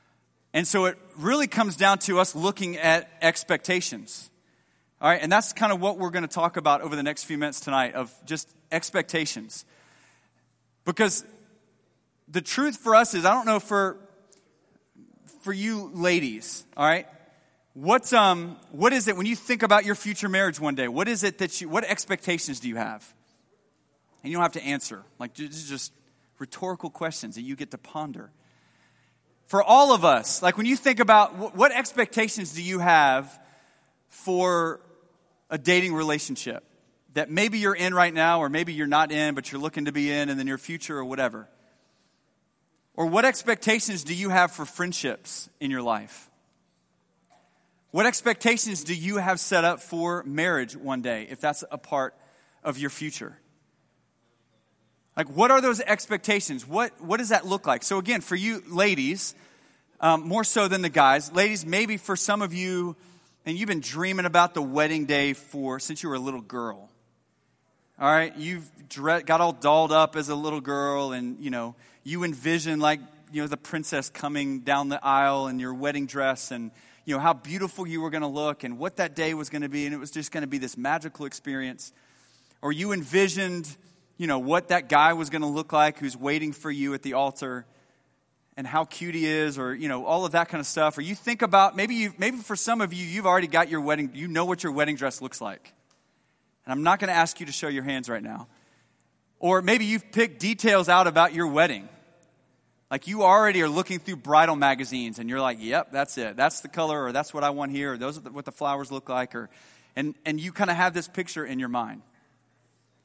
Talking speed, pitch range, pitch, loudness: 205 wpm, 140-185 Hz, 160 Hz, -24 LUFS